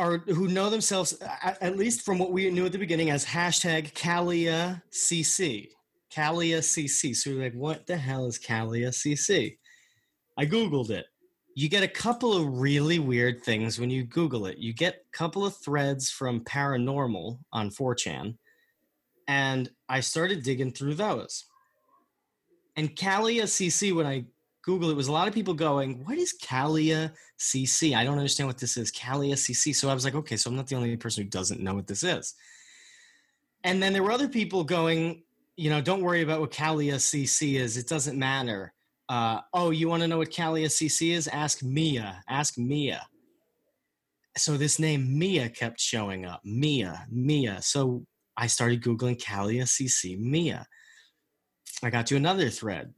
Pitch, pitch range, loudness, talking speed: 150 Hz, 125-175 Hz, -27 LUFS, 175 wpm